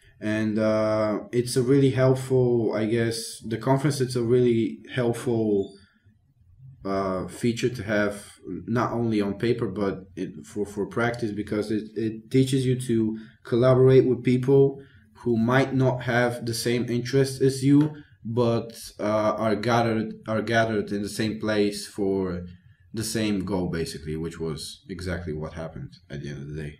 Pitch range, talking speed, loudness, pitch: 100-125 Hz, 160 wpm, -25 LUFS, 110 Hz